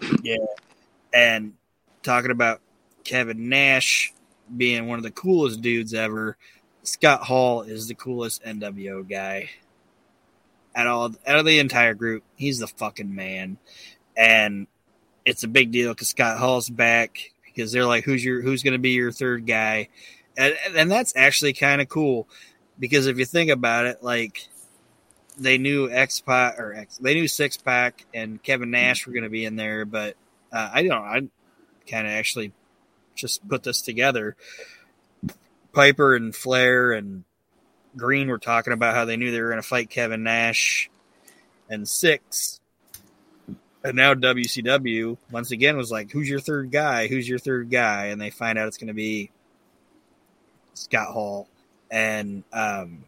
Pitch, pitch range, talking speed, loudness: 120 Hz, 110-130 Hz, 165 wpm, -21 LUFS